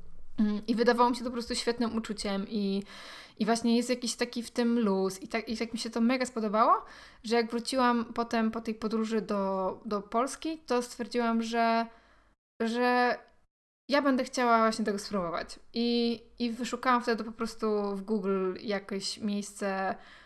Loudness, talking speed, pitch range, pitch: -30 LUFS, 170 wpm, 215-240 Hz, 230 Hz